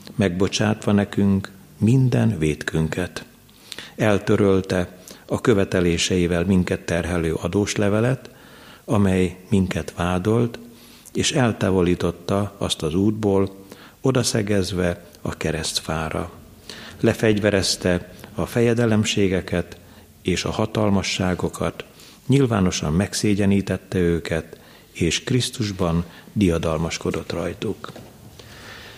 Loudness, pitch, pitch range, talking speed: -22 LUFS, 95 Hz, 90-110 Hz, 70 wpm